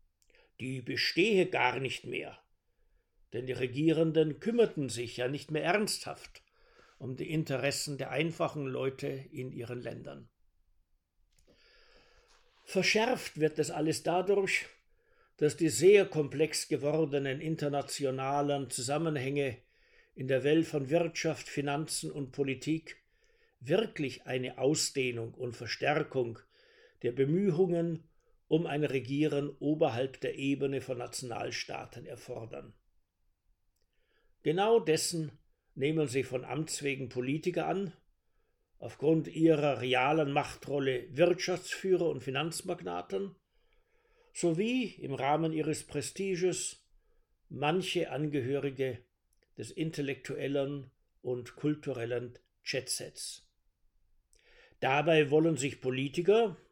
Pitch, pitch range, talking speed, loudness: 145 Hz, 130-165 Hz, 95 wpm, -32 LUFS